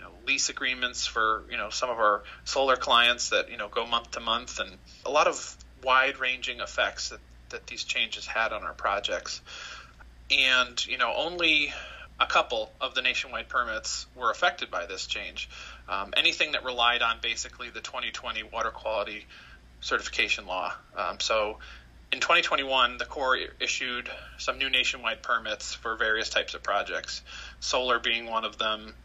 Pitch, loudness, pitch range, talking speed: 120 Hz, -27 LUFS, 110-130 Hz, 165 wpm